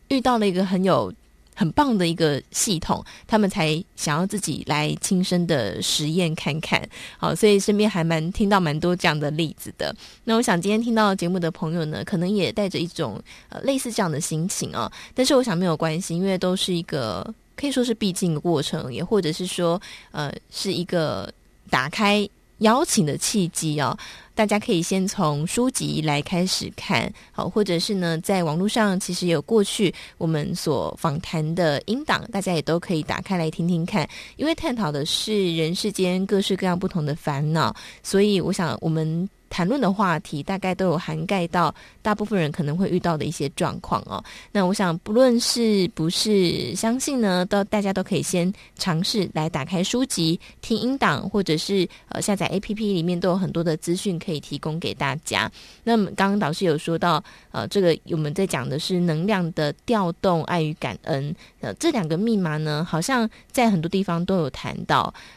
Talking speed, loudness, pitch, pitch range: 285 characters per minute, -23 LUFS, 180 Hz, 165-205 Hz